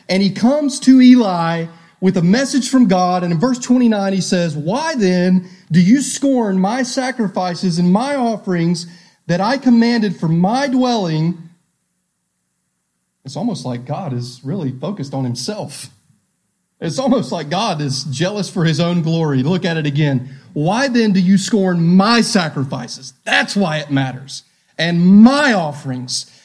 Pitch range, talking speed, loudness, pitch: 155-230 Hz, 155 wpm, -15 LUFS, 180 Hz